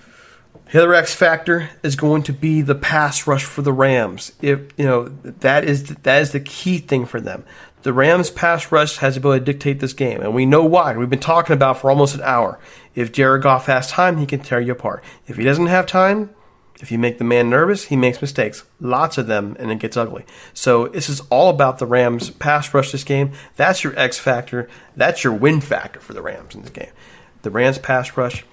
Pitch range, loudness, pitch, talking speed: 125-155 Hz, -17 LUFS, 140 Hz, 230 wpm